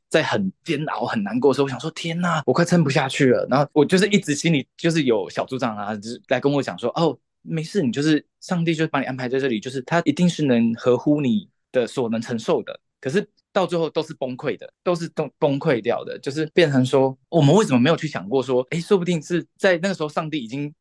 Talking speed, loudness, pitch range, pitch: 370 characters per minute, -21 LUFS, 130-170 Hz, 155 Hz